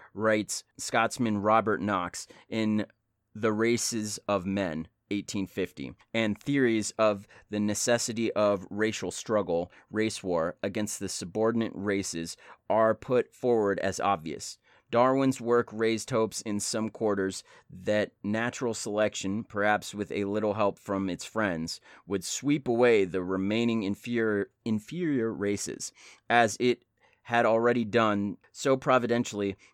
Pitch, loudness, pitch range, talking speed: 105 Hz, -29 LUFS, 100-115 Hz, 125 wpm